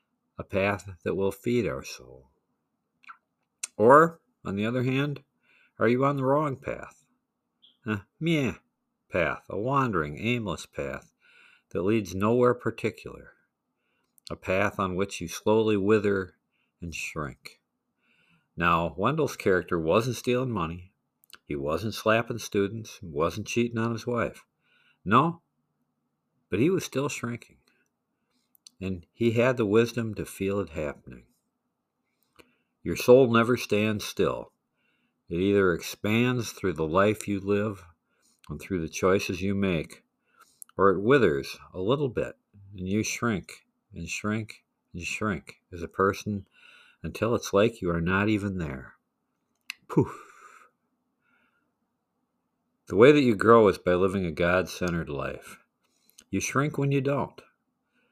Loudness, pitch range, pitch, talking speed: -26 LUFS, 95-120 Hz, 105 Hz, 135 wpm